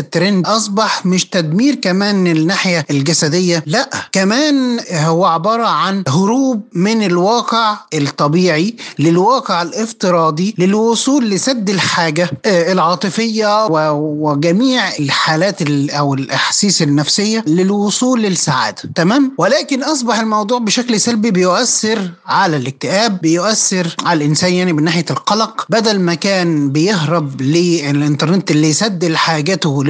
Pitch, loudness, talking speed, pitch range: 180 Hz, -13 LUFS, 105 wpm, 160-220 Hz